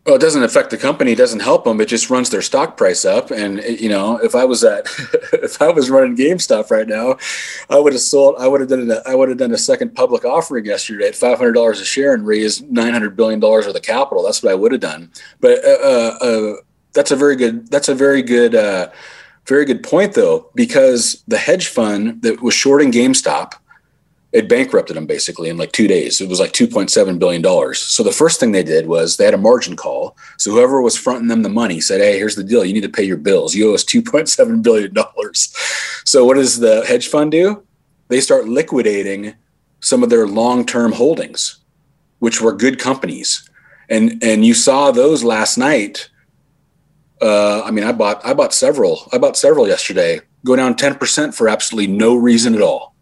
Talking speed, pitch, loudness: 225 wpm, 185 Hz, -14 LUFS